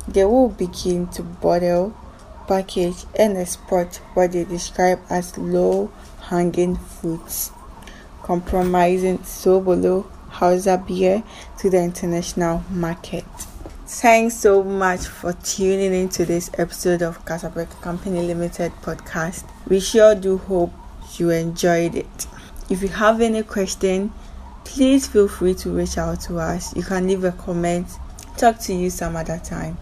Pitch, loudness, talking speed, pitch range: 180 Hz, -20 LUFS, 135 wpm, 175-195 Hz